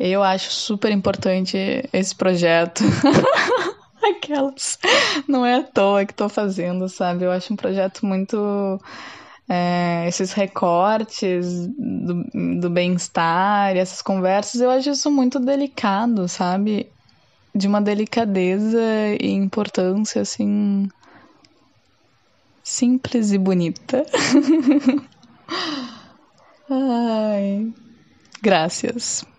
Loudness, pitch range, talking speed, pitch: -20 LUFS, 190-250 Hz, 95 wpm, 210 Hz